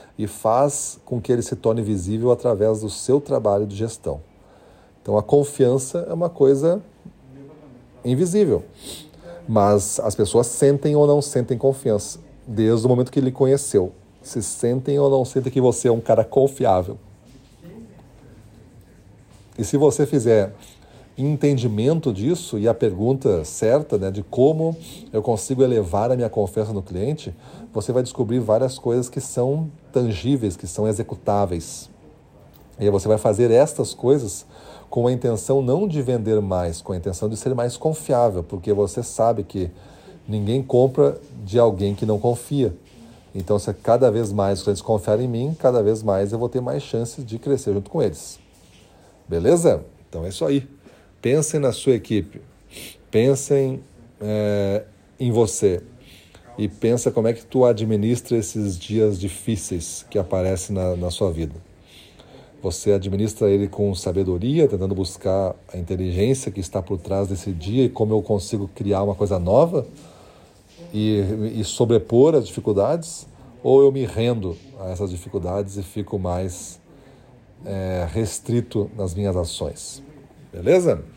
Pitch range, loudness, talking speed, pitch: 100-130 Hz, -21 LUFS, 150 wpm, 110 Hz